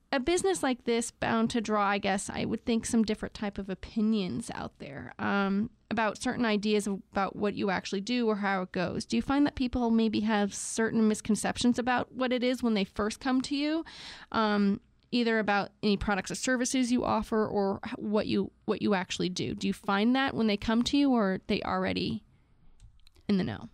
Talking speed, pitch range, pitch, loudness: 210 wpm, 205-245 Hz, 220 Hz, -29 LUFS